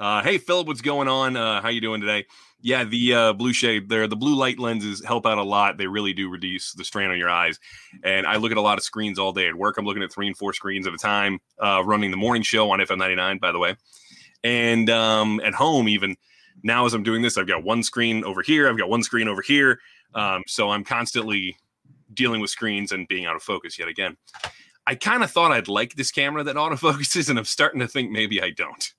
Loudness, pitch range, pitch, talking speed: -22 LUFS, 100-120 Hz, 110 Hz, 250 wpm